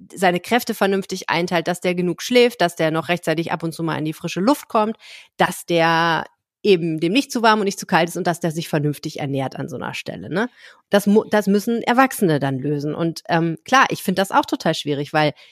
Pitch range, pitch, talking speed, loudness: 160-205 Hz, 175 Hz, 230 wpm, -20 LUFS